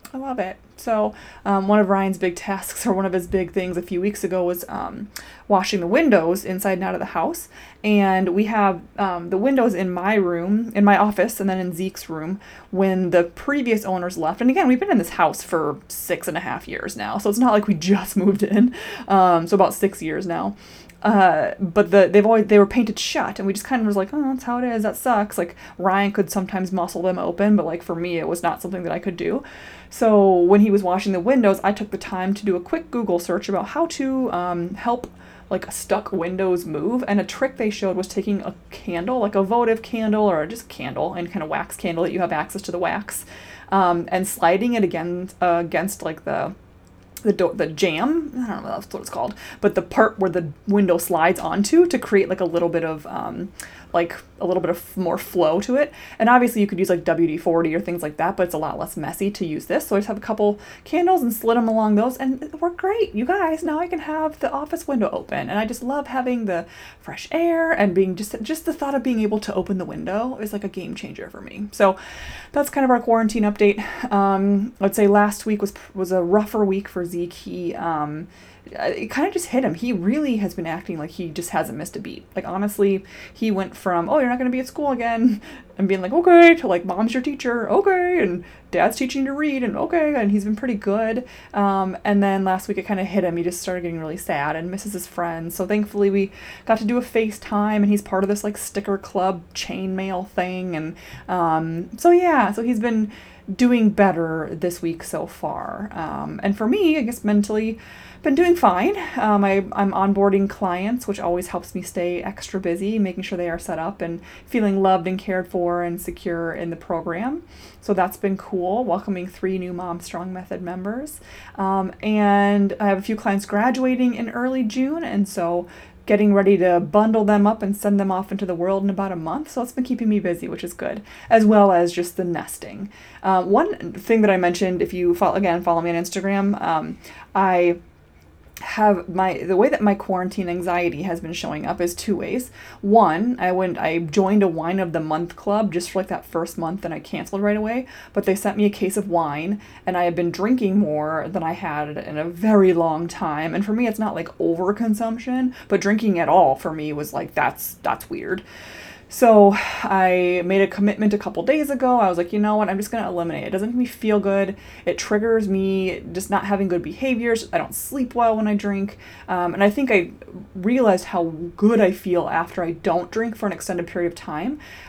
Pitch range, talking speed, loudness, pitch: 180-220 Hz, 230 wpm, -21 LUFS, 195 Hz